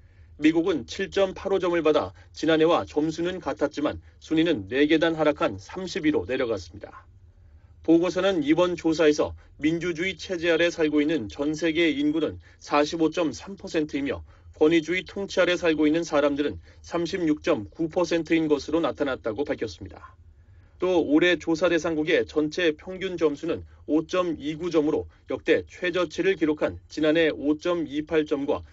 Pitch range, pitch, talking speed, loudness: 145-175 Hz, 155 Hz, 265 characters per minute, -25 LUFS